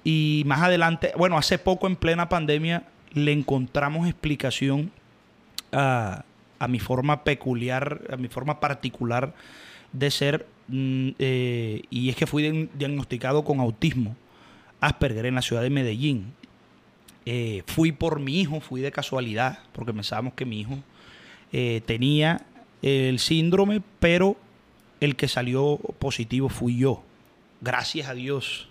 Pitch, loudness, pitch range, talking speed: 140 Hz, -25 LUFS, 125-155 Hz, 135 wpm